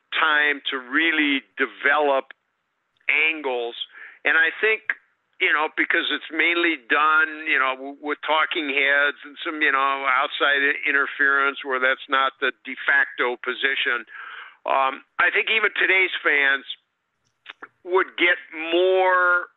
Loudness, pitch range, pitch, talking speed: -20 LUFS, 135-170 Hz, 145 Hz, 125 wpm